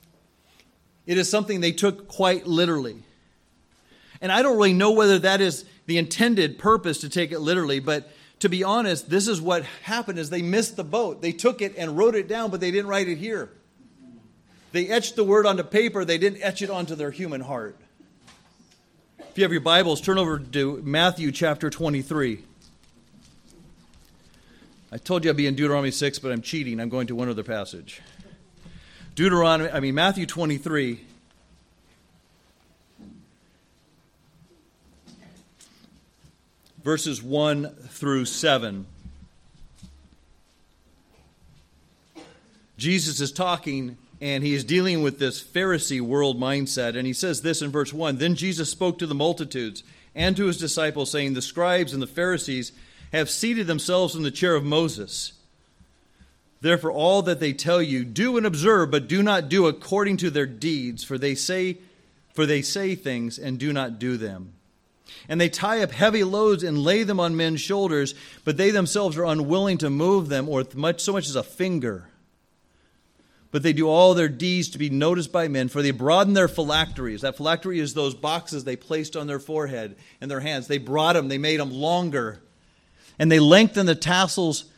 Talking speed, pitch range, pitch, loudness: 170 wpm, 135-185 Hz, 160 Hz, -23 LUFS